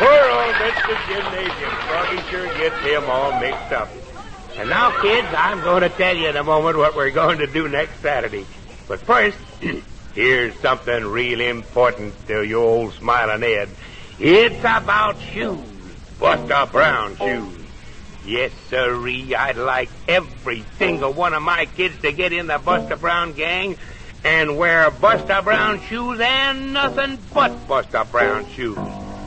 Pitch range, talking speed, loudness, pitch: 140-215 Hz, 150 wpm, -18 LUFS, 165 Hz